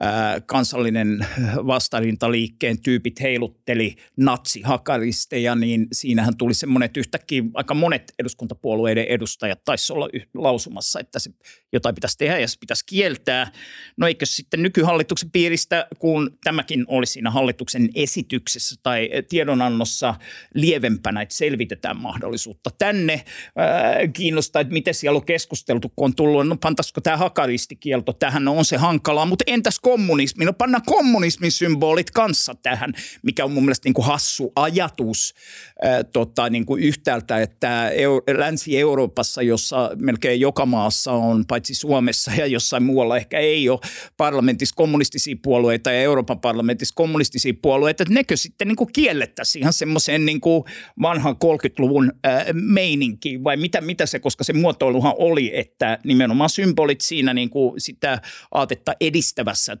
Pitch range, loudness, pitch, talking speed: 120-160 Hz, -20 LUFS, 140 Hz, 140 wpm